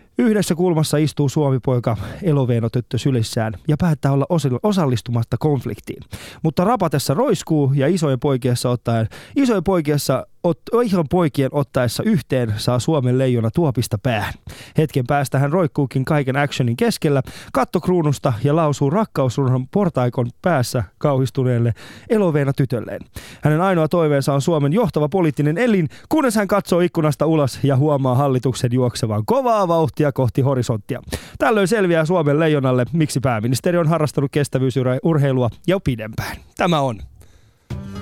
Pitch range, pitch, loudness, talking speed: 125-165 Hz, 140 Hz, -19 LUFS, 130 wpm